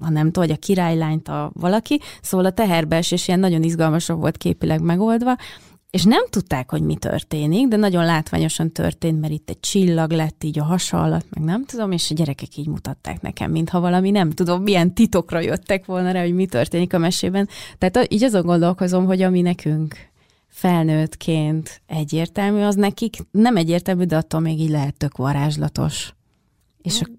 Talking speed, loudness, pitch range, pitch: 180 wpm, -20 LUFS, 155-190 Hz, 170 Hz